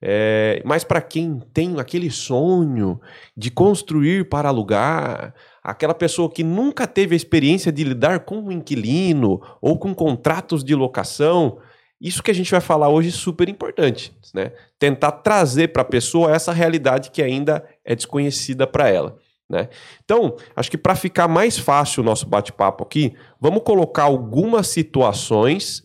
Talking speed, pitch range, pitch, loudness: 160 wpm, 130-170 Hz, 155 Hz, -19 LUFS